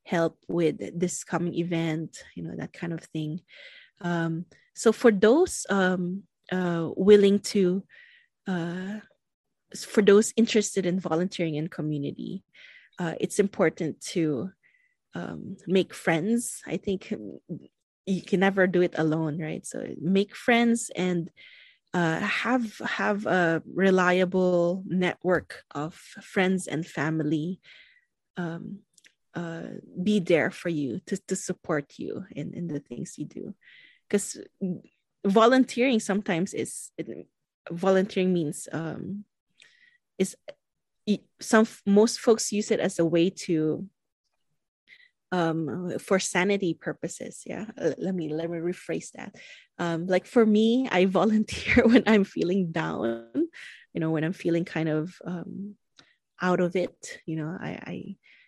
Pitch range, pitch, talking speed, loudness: 165-210 Hz, 185 Hz, 130 wpm, -26 LUFS